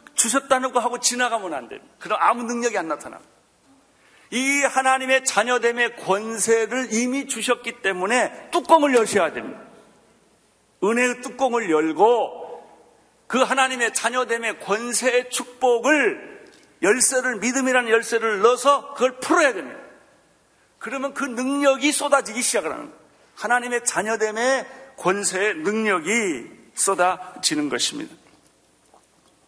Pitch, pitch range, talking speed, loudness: 245 Hz, 225-265 Hz, 285 characters per minute, -21 LUFS